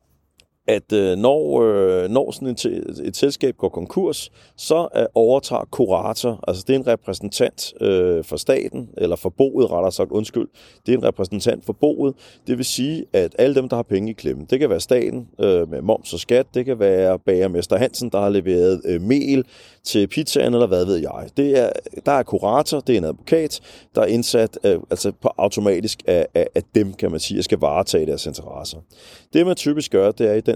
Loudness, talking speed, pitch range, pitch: -20 LUFS, 200 wpm, 95-145 Hz, 120 Hz